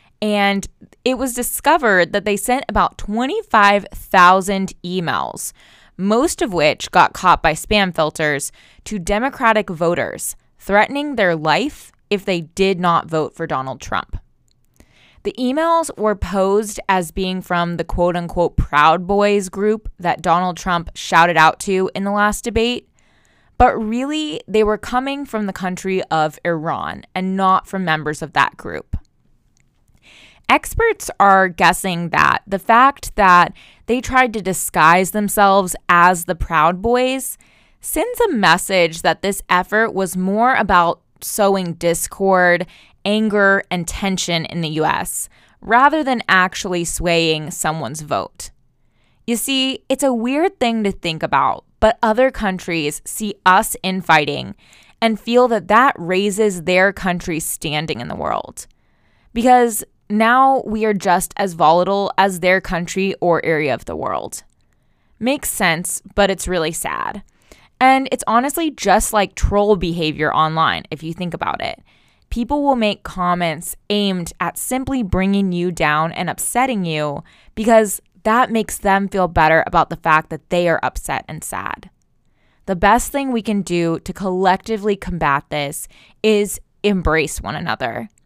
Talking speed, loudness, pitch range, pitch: 145 wpm, -17 LUFS, 170-220 Hz, 190 Hz